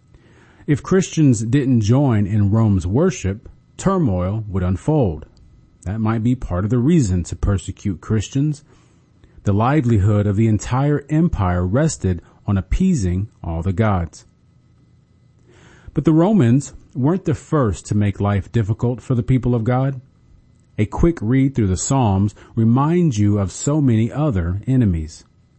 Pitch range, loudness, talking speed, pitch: 100-135 Hz, -19 LUFS, 140 wpm, 115 Hz